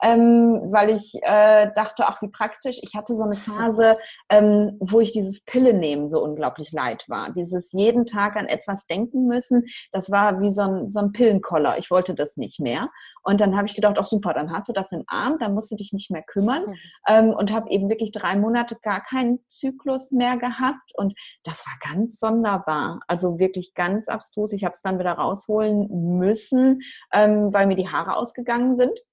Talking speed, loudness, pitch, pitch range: 200 wpm, -21 LUFS, 210 Hz, 195-230 Hz